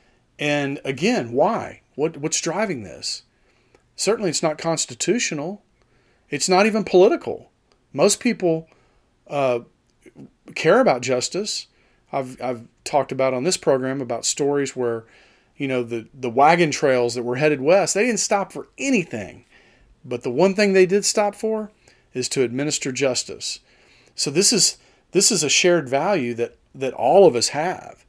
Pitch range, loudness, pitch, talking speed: 125-190 Hz, -20 LUFS, 145 Hz, 155 wpm